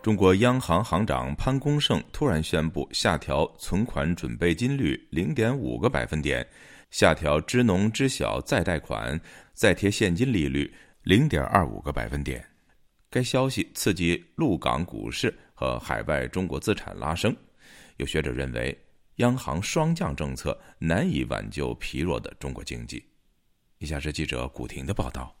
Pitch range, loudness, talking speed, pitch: 65-110 Hz, -26 LUFS, 240 characters per minute, 75 Hz